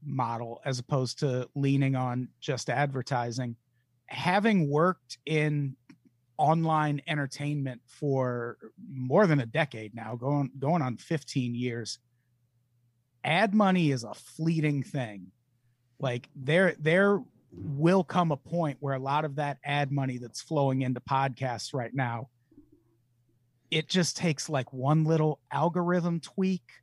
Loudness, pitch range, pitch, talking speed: -29 LUFS, 125-155 Hz, 140 Hz, 130 wpm